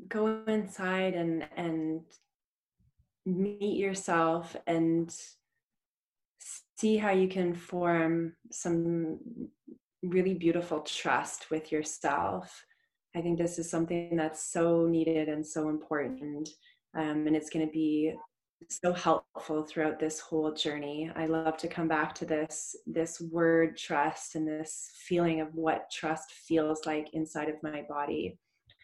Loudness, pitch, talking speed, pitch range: -32 LUFS, 165 Hz, 130 wpm, 155-180 Hz